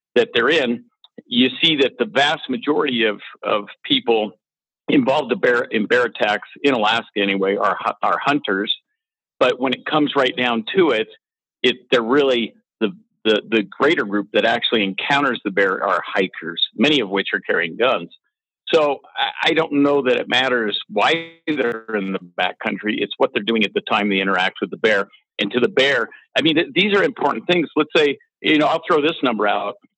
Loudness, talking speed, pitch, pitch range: -19 LUFS, 190 wpm, 125 Hz, 105-160 Hz